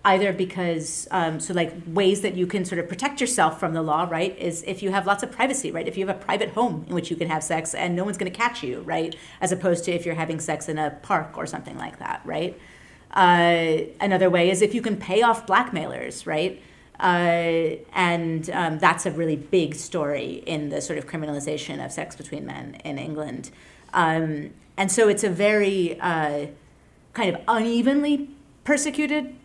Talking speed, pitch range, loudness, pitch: 205 wpm, 160-200 Hz, -24 LUFS, 180 Hz